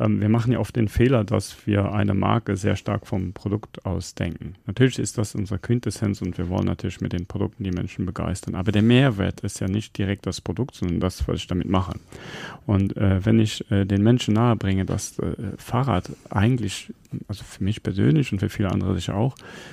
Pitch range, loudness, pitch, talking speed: 95-110 Hz, -24 LUFS, 105 Hz, 205 wpm